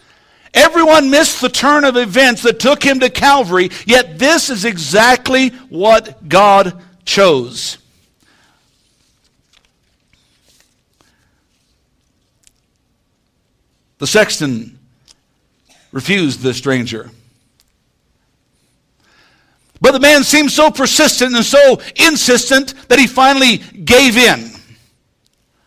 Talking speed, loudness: 85 wpm, -10 LUFS